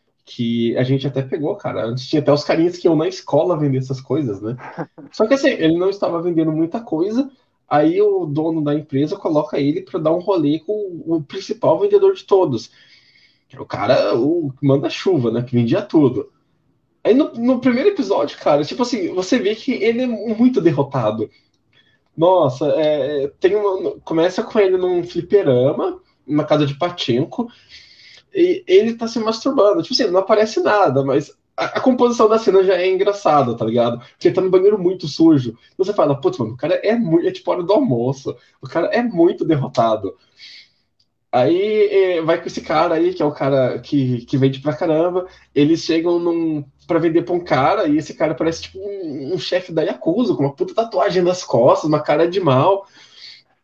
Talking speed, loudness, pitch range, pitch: 190 wpm, -18 LUFS, 145-245 Hz, 180 Hz